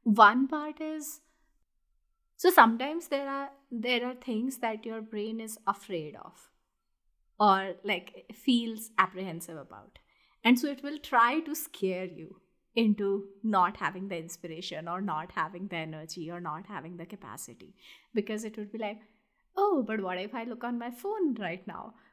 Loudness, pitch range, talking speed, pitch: -30 LUFS, 185-255 Hz, 165 wpm, 220 Hz